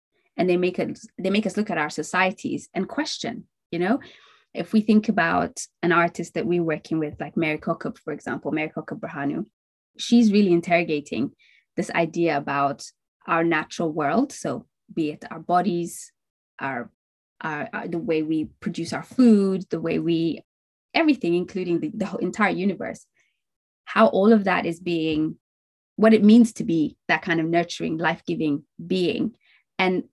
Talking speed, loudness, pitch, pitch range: 165 wpm, -23 LUFS, 175 Hz, 160-215 Hz